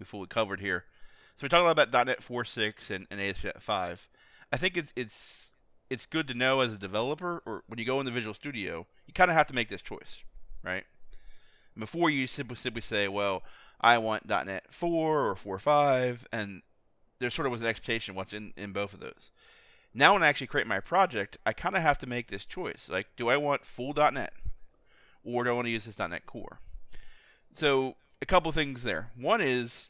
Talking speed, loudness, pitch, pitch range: 210 wpm, -30 LUFS, 125 Hz, 110-145 Hz